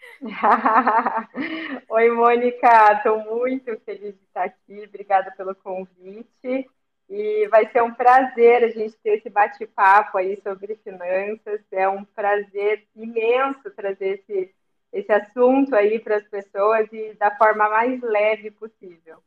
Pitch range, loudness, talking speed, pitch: 200-235 Hz, -20 LUFS, 130 wpm, 215 Hz